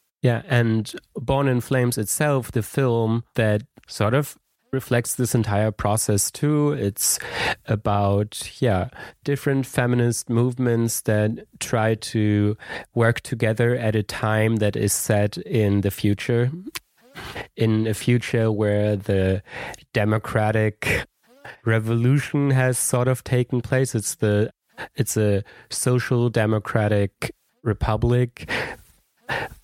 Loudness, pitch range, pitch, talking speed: -22 LUFS, 105-125 Hz, 115 Hz, 110 wpm